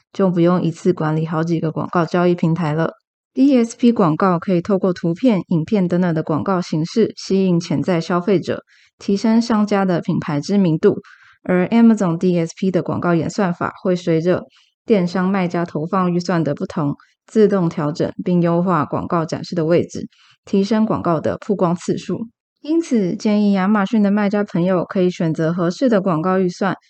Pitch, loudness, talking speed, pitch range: 180 Hz, -18 LUFS, 290 characters per minute, 165-200 Hz